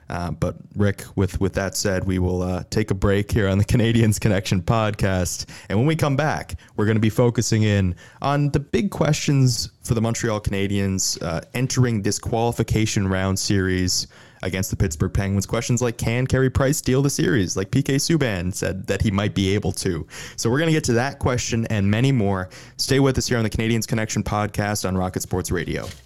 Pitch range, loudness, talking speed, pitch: 95-125 Hz, -22 LUFS, 205 wpm, 110 Hz